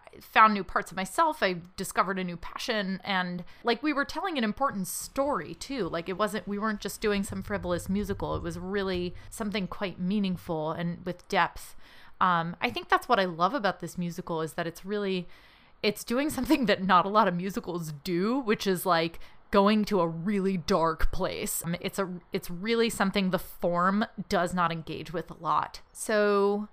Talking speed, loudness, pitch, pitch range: 195 wpm, -29 LUFS, 195 Hz, 175-215 Hz